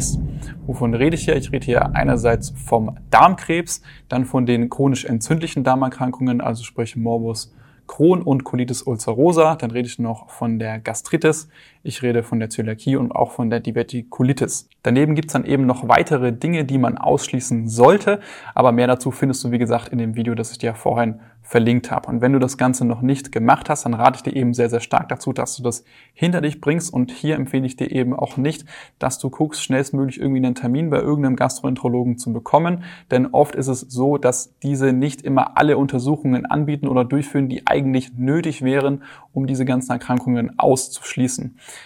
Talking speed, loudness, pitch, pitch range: 195 wpm, -19 LUFS, 130 Hz, 120-140 Hz